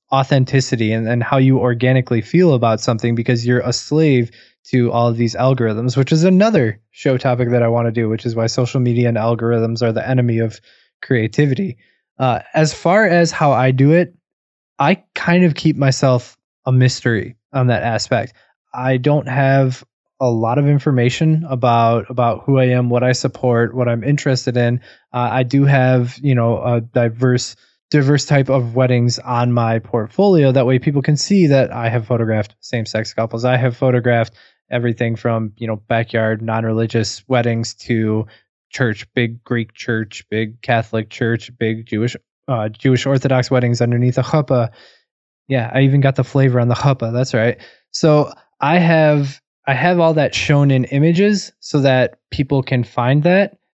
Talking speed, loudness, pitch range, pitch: 175 wpm, -16 LUFS, 115-135 Hz, 125 Hz